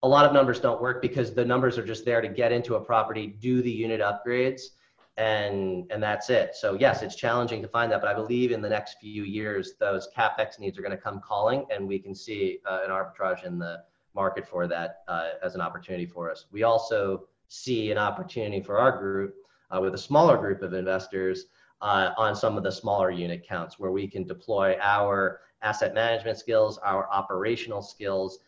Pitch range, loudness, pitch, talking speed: 95-120 Hz, -27 LUFS, 105 Hz, 210 wpm